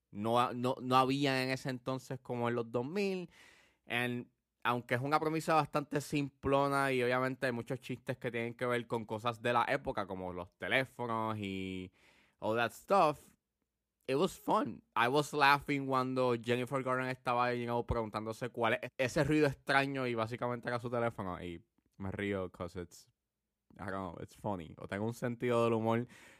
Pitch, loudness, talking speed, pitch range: 120 Hz, -35 LUFS, 180 wpm, 115-130 Hz